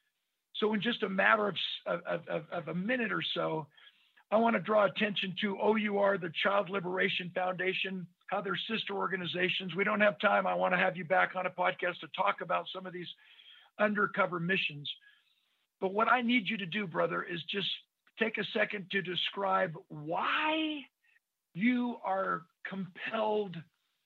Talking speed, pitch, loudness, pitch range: 165 wpm, 195 Hz, -32 LUFS, 180-215 Hz